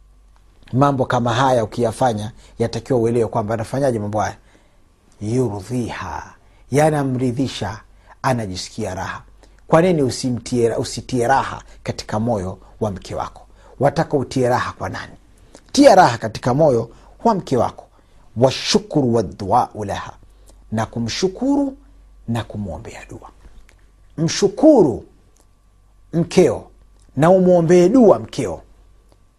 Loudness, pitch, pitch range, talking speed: -18 LUFS, 115 Hz, 100-135 Hz, 100 wpm